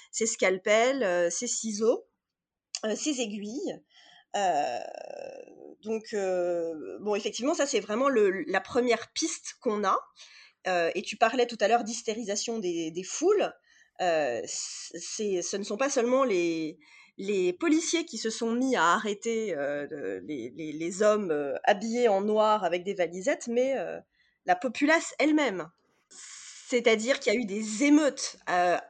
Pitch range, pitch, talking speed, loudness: 195-275 Hz, 225 Hz, 155 wpm, -28 LUFS